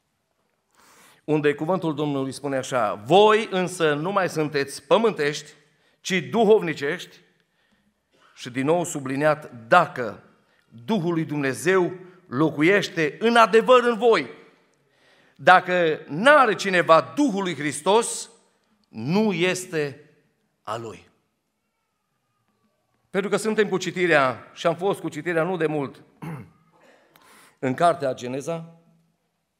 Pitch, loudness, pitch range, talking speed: 165 Hz, -22 LUFS, 150-195 Hz, 100 wpm